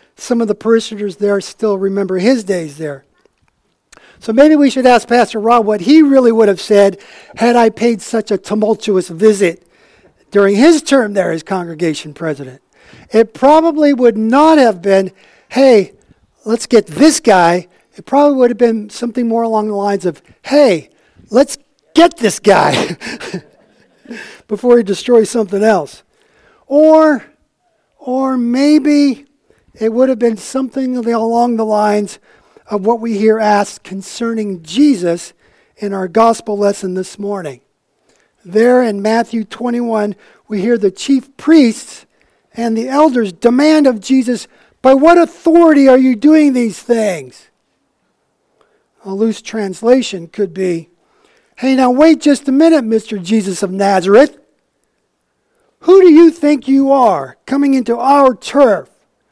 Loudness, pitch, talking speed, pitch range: -12 LUFS, 230 Hz, 145 wpm, 205-270 Hz